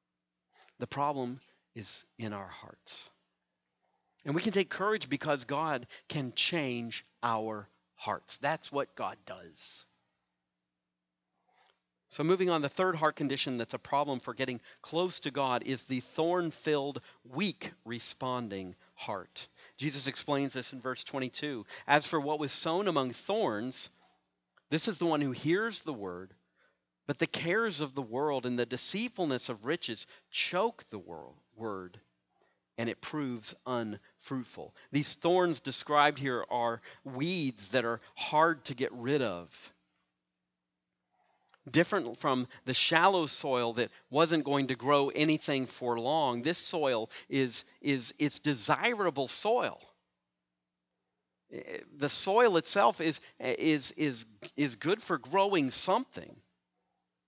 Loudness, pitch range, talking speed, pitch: -32 LUFS, 115-150 Hz, 135 wpm, 130 Hz